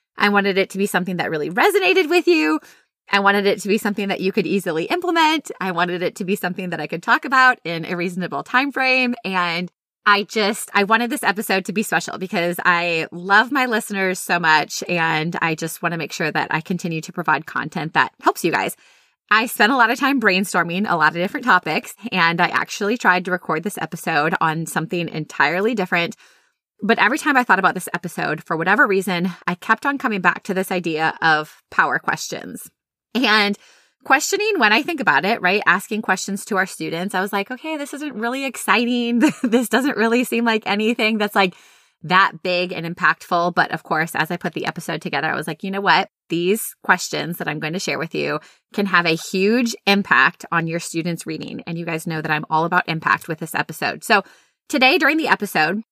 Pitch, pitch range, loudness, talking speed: 190 Hz, 170-225 Hz, -19 LUFS, 215 wpm